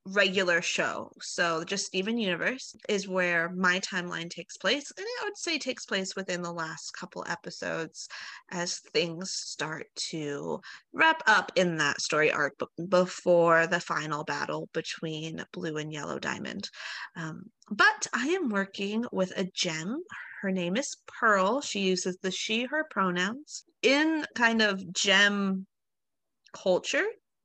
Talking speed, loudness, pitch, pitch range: 140 wpm, -28 LUFS, 190 Hz, 175-240 Hz